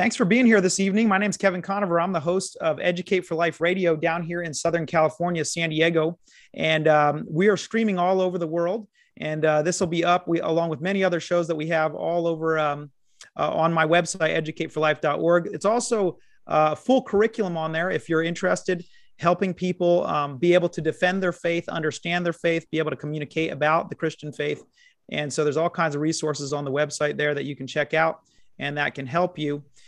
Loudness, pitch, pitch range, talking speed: -23 LUFS, 170 Hz, 155-180 Hz, 220 wpm